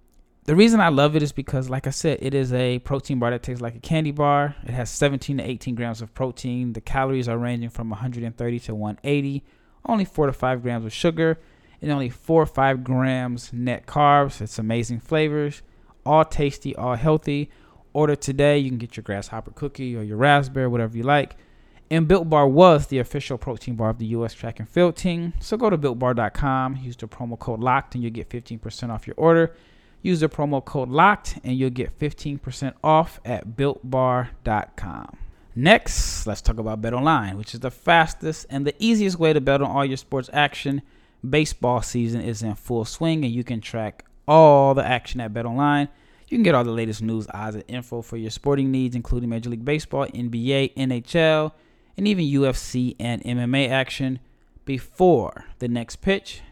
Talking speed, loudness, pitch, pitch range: 195 wpm, -22 LUFS, 130 Hz, 120-145 Hz